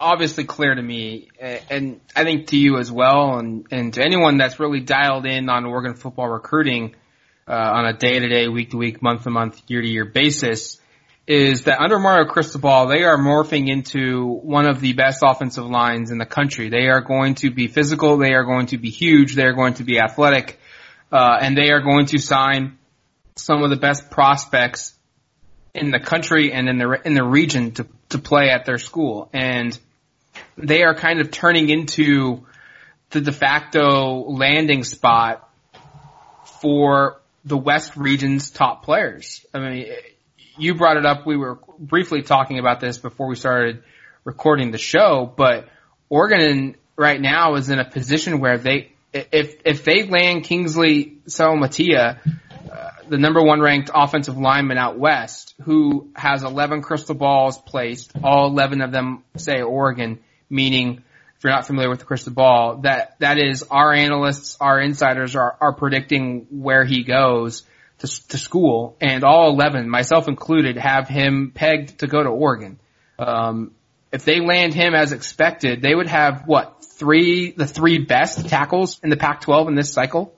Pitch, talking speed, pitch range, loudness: 140 Hz, 175 wpm, 125-150 Hz, -17 LUFS